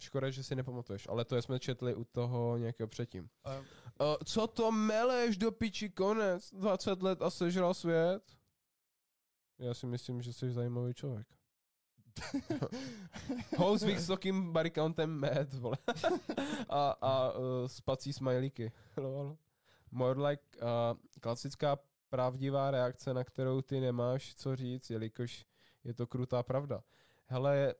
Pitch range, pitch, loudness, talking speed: 120-170 Hz, 135 Hz, -36 LUFS, 125 wpm